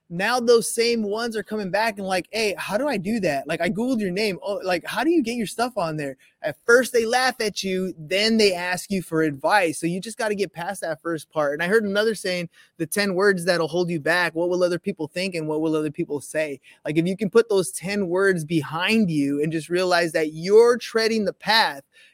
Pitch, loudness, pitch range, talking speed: 185 Hz, -22 LUFS, 165-215 Hz, 250 wpm